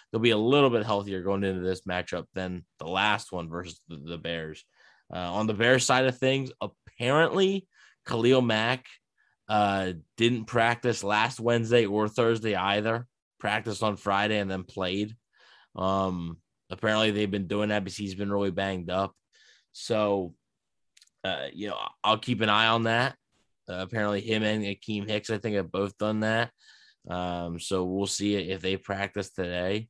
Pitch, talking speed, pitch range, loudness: 105 Hz, 165 wpm, 95-115 Hz, -28 LUFS